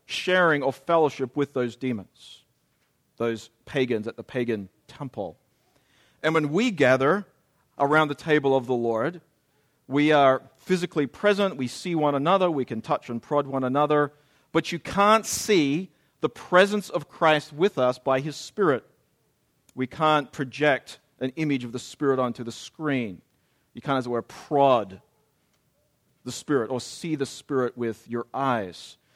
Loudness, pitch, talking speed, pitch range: -25 LUFS, 140 Hz, 155 wpm, 125-155 Hz